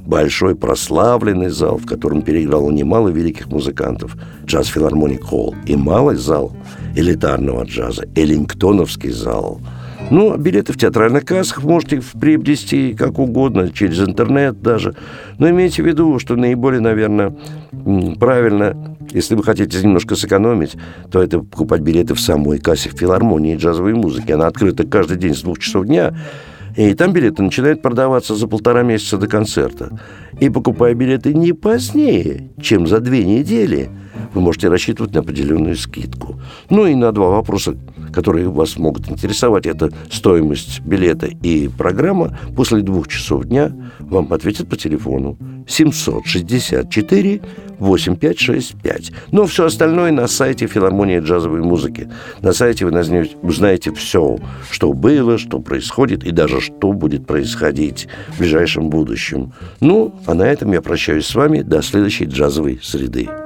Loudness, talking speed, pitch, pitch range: -15 LUFS, 140 wpm, 105 Hz, 85-130 Hz